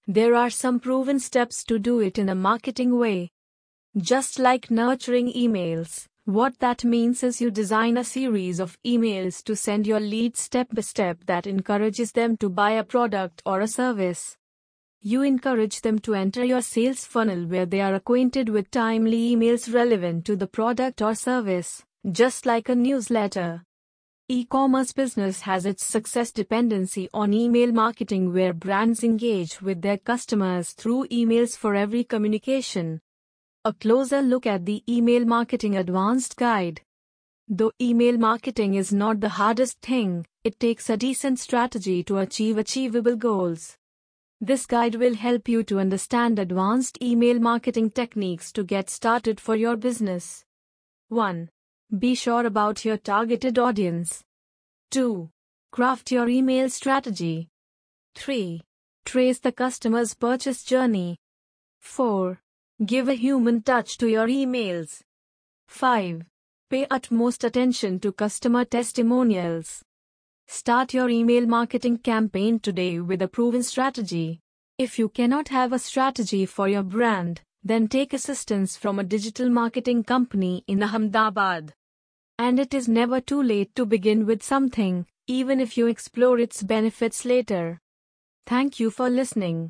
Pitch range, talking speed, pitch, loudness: 195-245 Hz, 145 wpm, 225 Hz, -23 LUFS